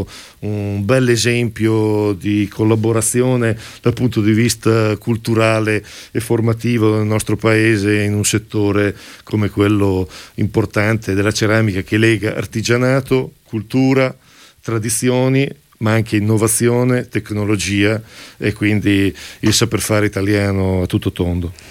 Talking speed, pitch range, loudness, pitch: 115 wpm, 105-115 Hz, -16 LUFS, 110 Hz